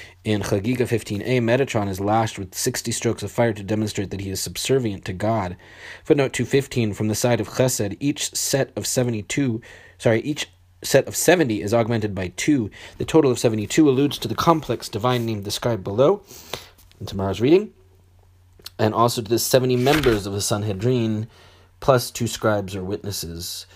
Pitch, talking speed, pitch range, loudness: 110 Hz, 170 wpm, 100-125 Hz, -22 LUFS